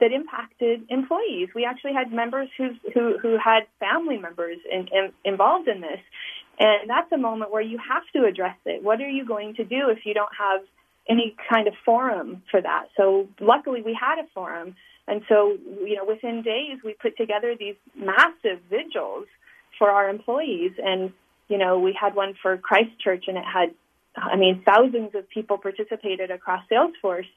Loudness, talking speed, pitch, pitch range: -23 LUFS, 185 wpm, 220 Hz, 195-260 Hz